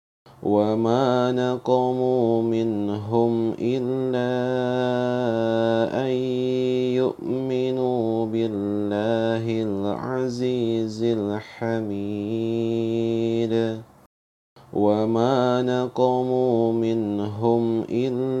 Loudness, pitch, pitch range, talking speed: -23 LUFS, 115 Hz, 115-125 Hz, 40 wpm